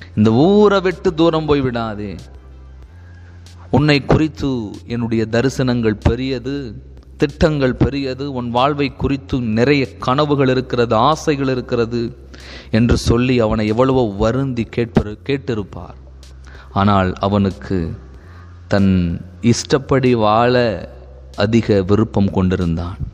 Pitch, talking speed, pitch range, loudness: 115 Hz, 90 wpm, 90-130 Hz, -17 LUFS